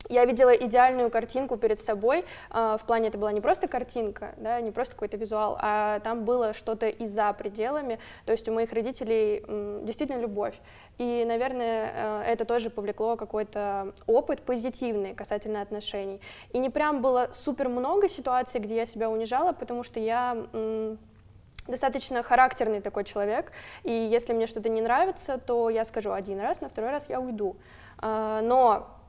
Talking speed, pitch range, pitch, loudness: 160 wpm, 215-250 Hz, 230 Hz, -28 LUFS